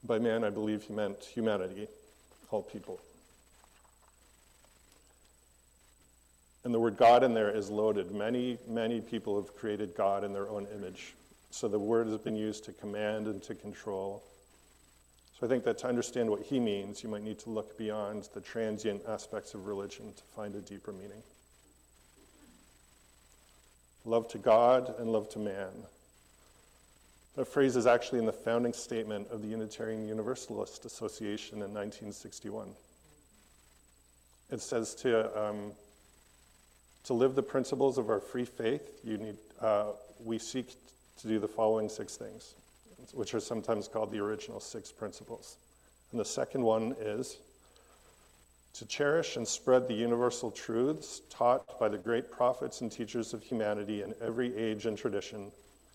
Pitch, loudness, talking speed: 105 Hz, -34 LUFS, 150 wpm